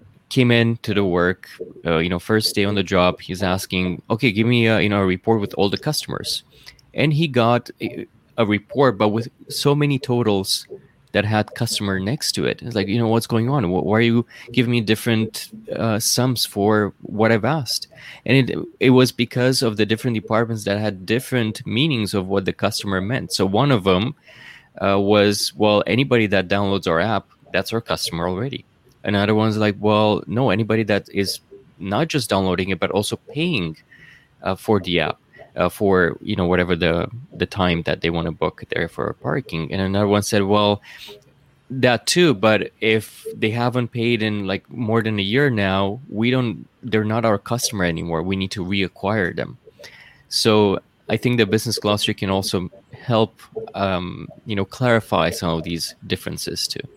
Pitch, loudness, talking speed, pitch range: 110 Hz, -20 LUFS, 190 wpm, 95-120 Hz